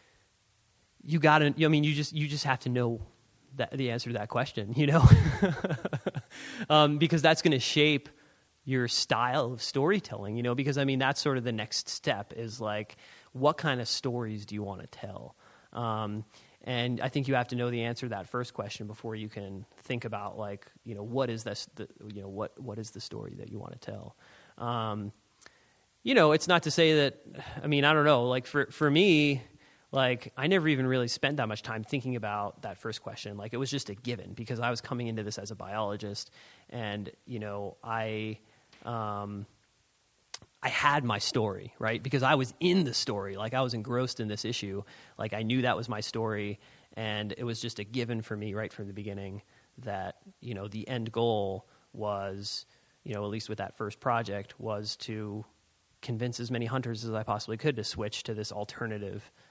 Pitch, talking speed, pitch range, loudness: 120 Hz, 210 wpm, 105-135 Hz, -30 LUFS